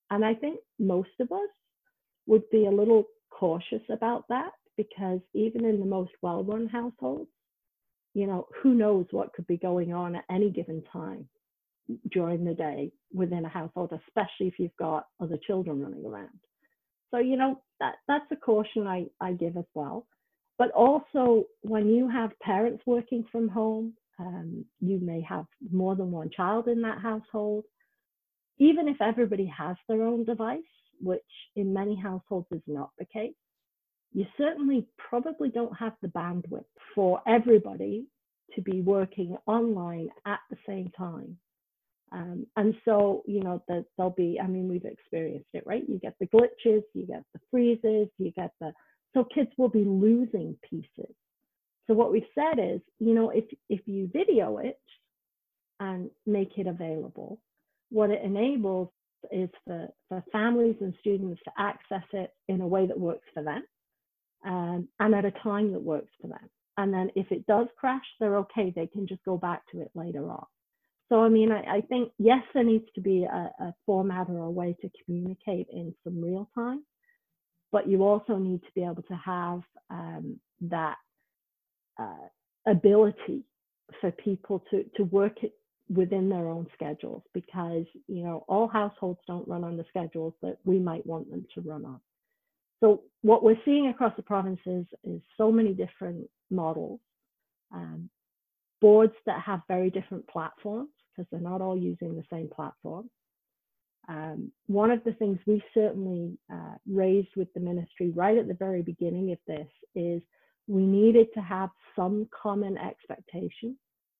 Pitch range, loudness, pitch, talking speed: 180-225 Hz, -28 LUFS, 200 Hz, 170 wpm